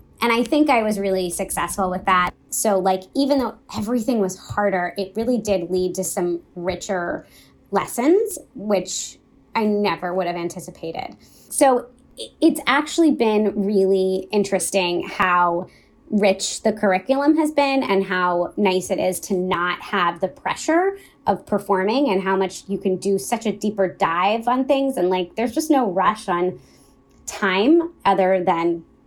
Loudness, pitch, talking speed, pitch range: -21 LUFS, 195 Hz, 155 wpm, 185-240 Hz